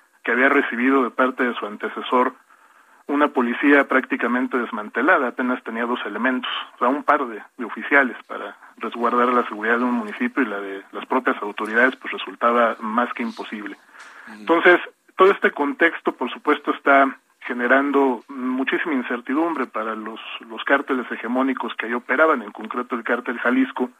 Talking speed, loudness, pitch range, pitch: 160 wpm, -20 LUFS, 120-140 Hz, 130 Hz